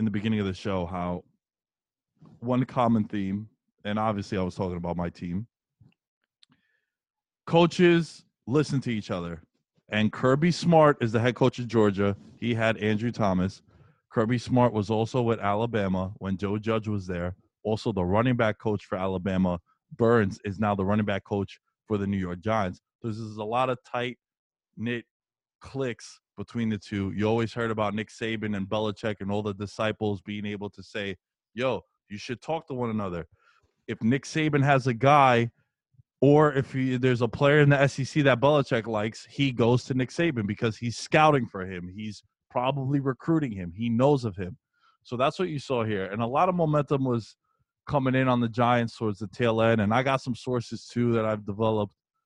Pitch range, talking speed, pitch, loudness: 105-130 Hz, 190 wpm, 115 Hz, -26 LUFS